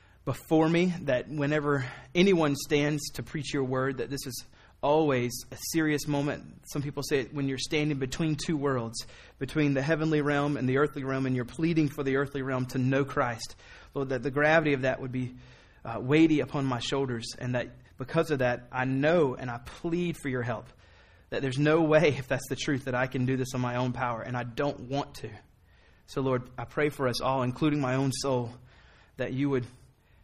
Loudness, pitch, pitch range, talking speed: -29 LUFS, 135 Hz, 125-150 Hz, 210 wpm